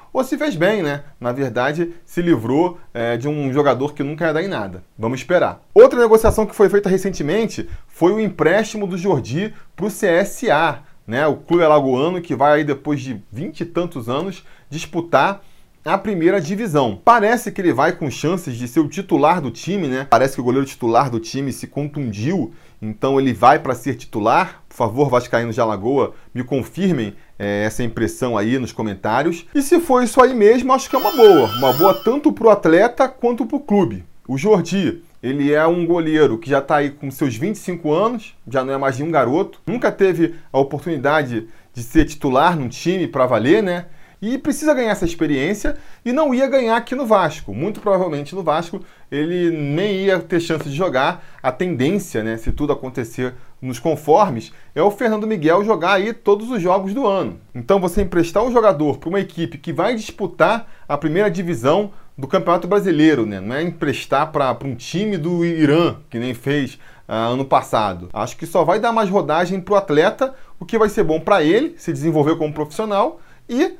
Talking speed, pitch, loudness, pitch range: 200 wpm, 165 Hz, -18 LUFS, 135-200 Hz